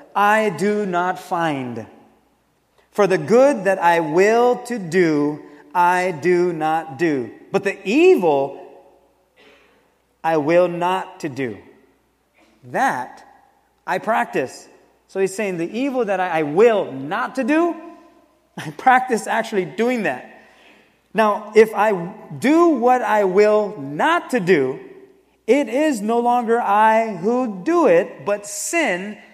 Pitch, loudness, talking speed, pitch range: 210 Hz, -18 LUFS, 130 wpm, 180-255 Hz